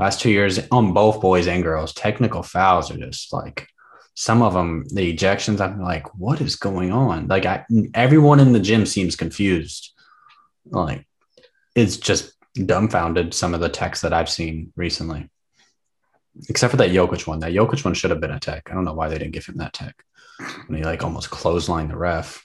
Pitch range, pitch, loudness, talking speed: 85-110 Hz, 95 Hz, -20 LUFS, 200 wpm